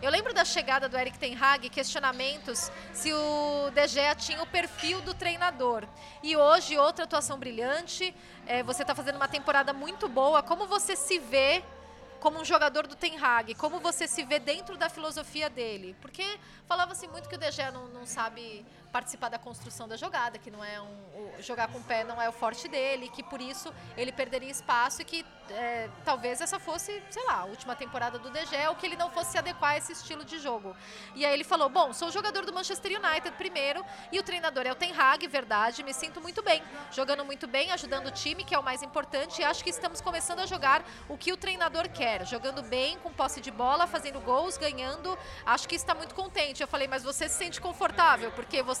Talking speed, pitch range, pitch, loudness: 220 wpm, 260-340 Hz, 295 Hz, -30 LUFS